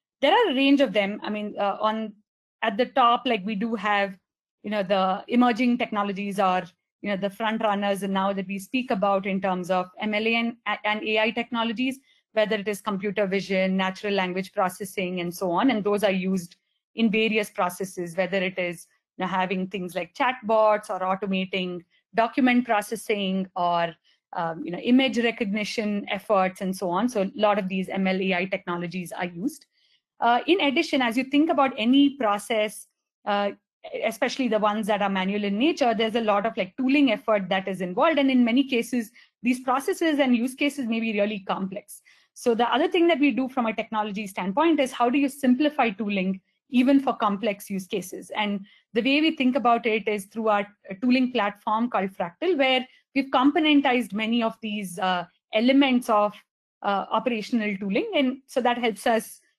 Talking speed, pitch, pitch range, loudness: 190 wpm, 215 Hz, 195-250 Hz, -24 LUFS